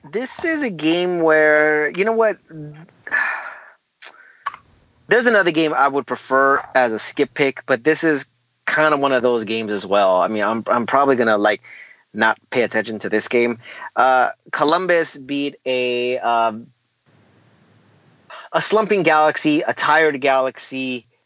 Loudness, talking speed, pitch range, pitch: -18 LUFS, 150 wpm, 120-155 Hz, 140 Hz